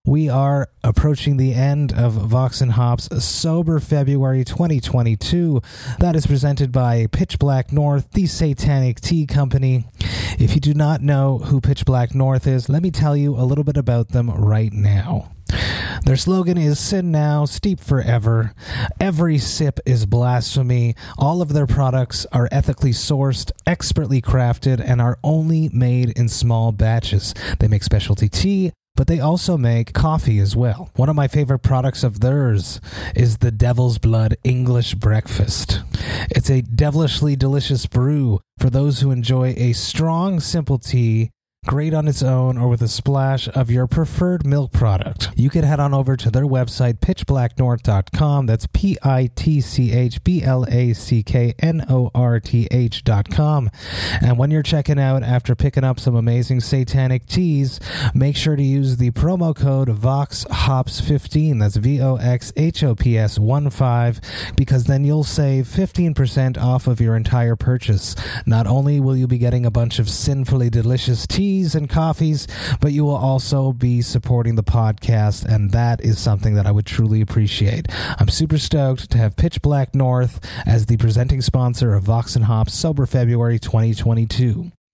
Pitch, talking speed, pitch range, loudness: 125 Hz, 155 wpm, 115-140 Hz, -18 LUFS